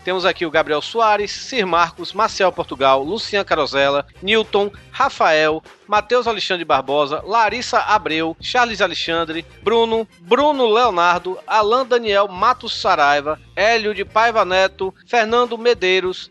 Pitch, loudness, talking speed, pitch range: 195 Hz, -17 LUFS, 120 wpm, 165-225 Hz